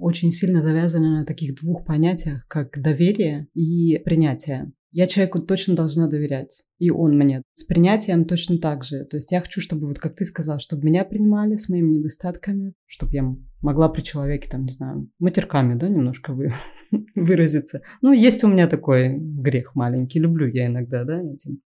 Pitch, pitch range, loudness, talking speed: 160 Hz, 140-175 Hz, -21 LUFS, 175 wpm